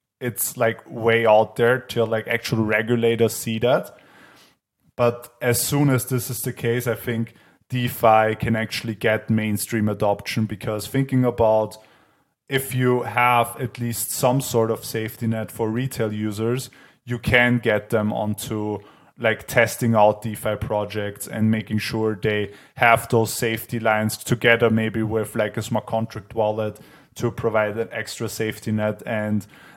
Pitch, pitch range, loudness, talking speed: 115 Hz, 110-120 Hz, -22 LUFS, 155 wpm